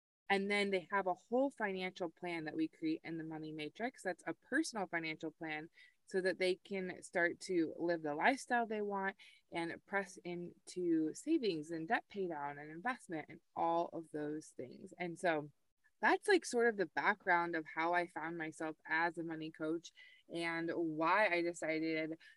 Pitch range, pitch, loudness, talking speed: 160-200 Hz, 175 Hz, -38 LUFS, 180 wpm